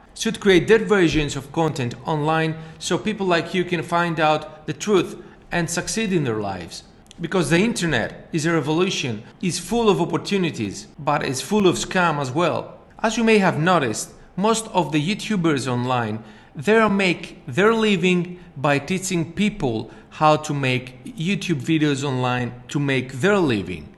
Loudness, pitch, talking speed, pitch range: -21 LUFS, 170 Hz, 165 wpm, 145-185 Hz